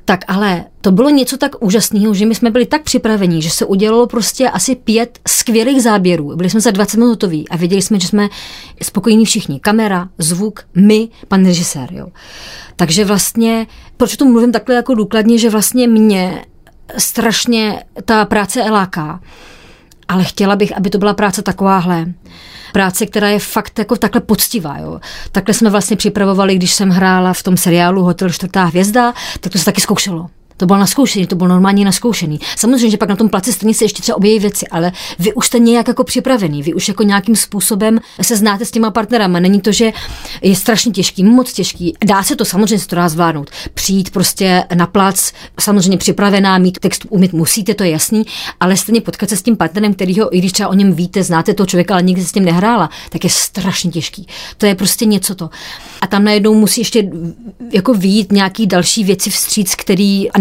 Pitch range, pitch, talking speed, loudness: 185-220 Hz, 205 Hz, 195 wpm, -12 LUFS